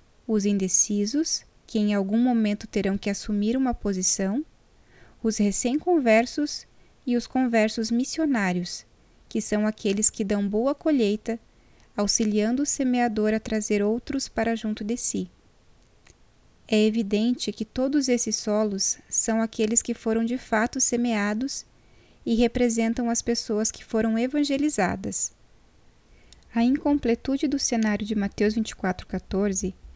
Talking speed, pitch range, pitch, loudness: 120 wpm, 210-245 Hz, 225 Hz, -25 LUFS